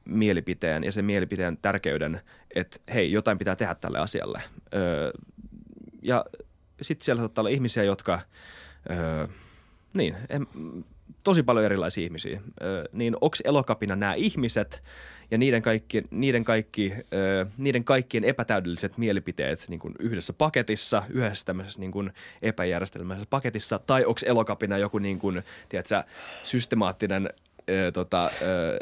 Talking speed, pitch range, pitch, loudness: 130 wpm, 95-115 Hz, 105 Hz, -27 LUFS